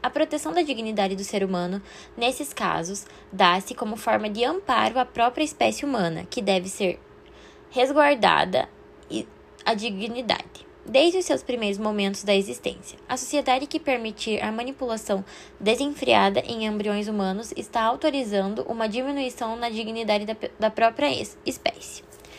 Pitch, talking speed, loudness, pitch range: 230 Hz, 135 wpm, -25 LUFS, 205-260 Hz